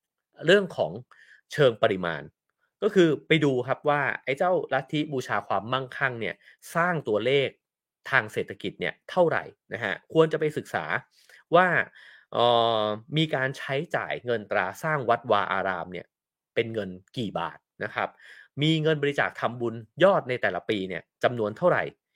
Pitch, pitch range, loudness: 130 Hz, 110-160 Hz, -26 LUFS